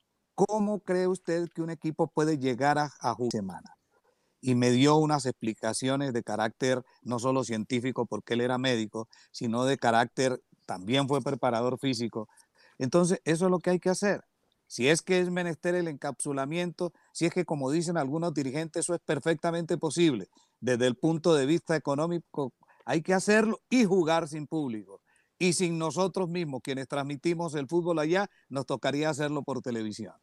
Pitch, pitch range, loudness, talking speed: 150 Hz, 130-170 Hz, -29 LUFS, 170 wpm